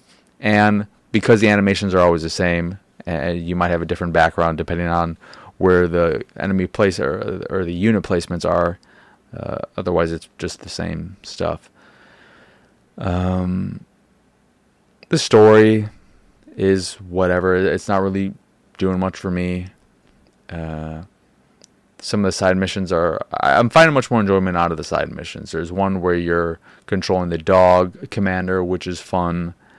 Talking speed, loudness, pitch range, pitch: 150 wpm, -18 LUFS, 85-95 Hz, 90 Hz